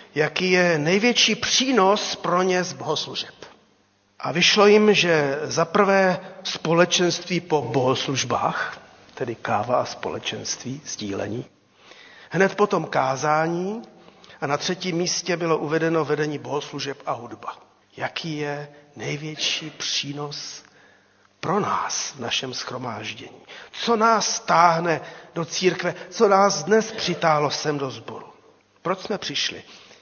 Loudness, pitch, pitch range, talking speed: -22 LUFS, 170 Hz, 150-190 Hz, 120 wpm